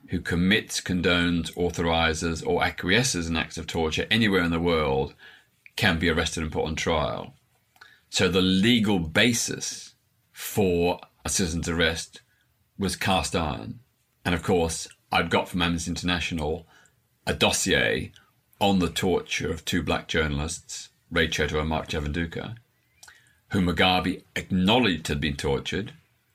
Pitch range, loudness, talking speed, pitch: 80-95 Hz, -25 LUFS, 135 wpm, 85 Hz